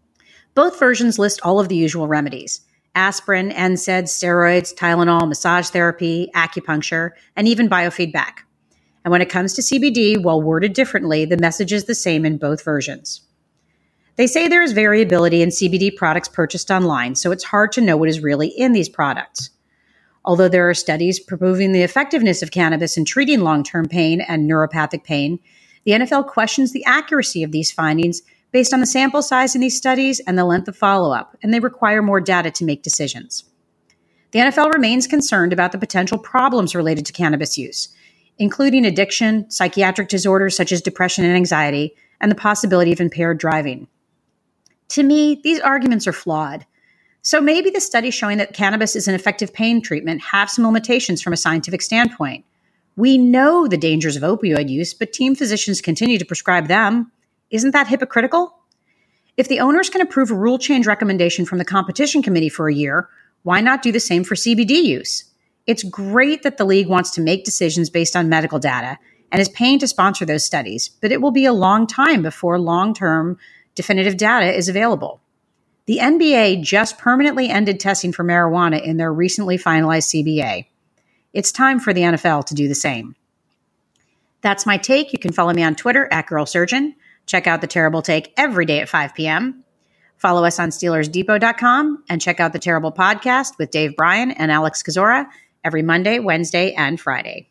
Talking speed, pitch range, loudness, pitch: 180 wpm, 165-230 Hz, -16 LUFS, 185 Hz